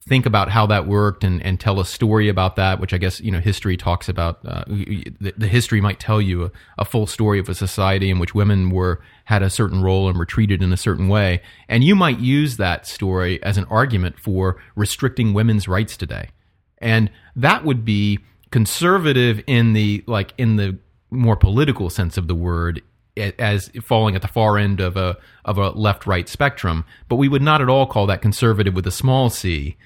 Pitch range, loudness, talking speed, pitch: 95-110 Hz, -19 LUFS, 210 wpm, 105 Hz